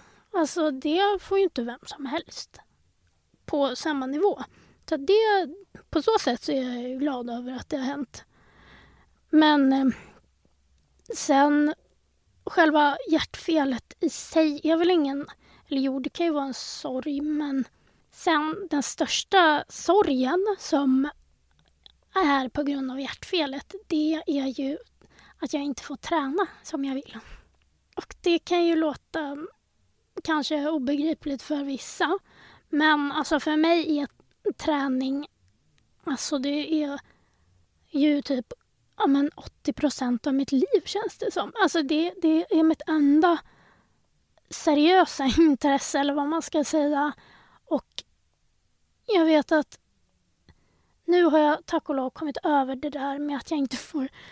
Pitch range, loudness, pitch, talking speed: 280-330 Hz, -25 LUFS, 300 Hz, 140 wpm